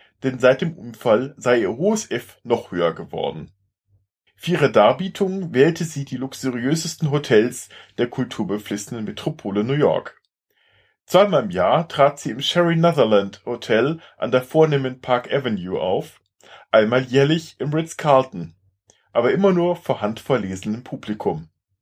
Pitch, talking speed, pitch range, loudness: 130 Hz, 135 wpm, 105-160 Hz, -20 LUFS